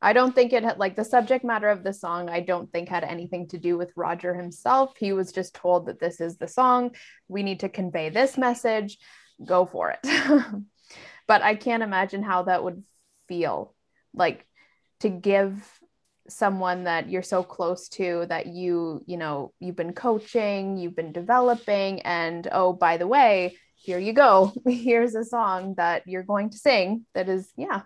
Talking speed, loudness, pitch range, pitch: 185 wpm, -24 LUFS, 175-225 Hz, 190 Hz